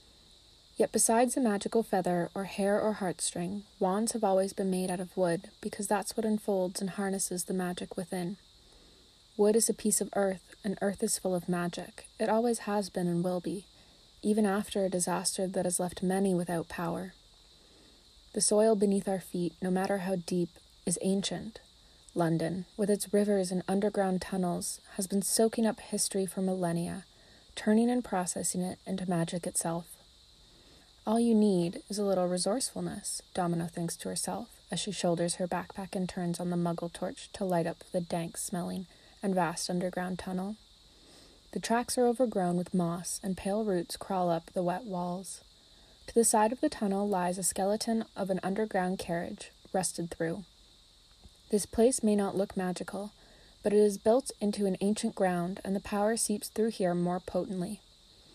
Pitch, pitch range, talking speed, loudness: 190 Hz, 180-210 Hz, 175 wpm, -31 LUFS